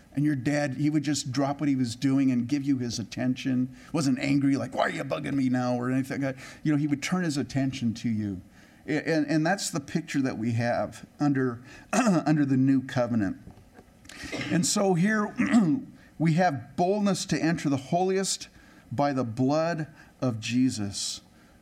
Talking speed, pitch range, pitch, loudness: 185 wpm, 125-155 Hz, 140 Hz, -27 LUFS